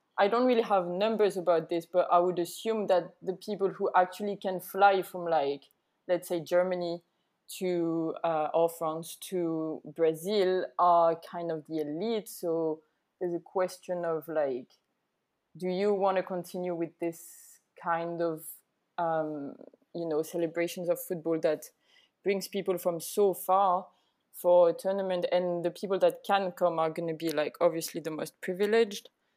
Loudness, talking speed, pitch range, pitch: -30 LUFS, 160 wpm, 165-190 Hz, 175 Hz